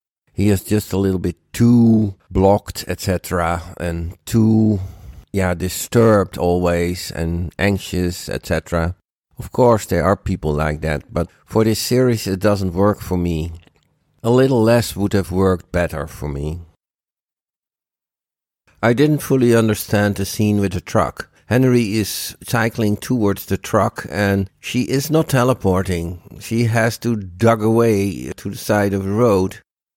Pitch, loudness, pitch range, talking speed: 100 Hz, -18 LUFS, 90-110 Hz, 145 wpm